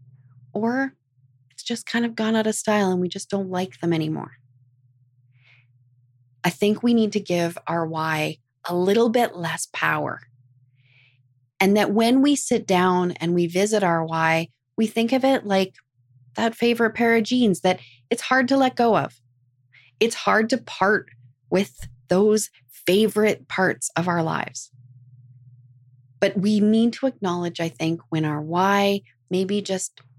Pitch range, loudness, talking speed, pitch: 125-215 Hz, -22 LUFS, 160 wpm, 175 Hz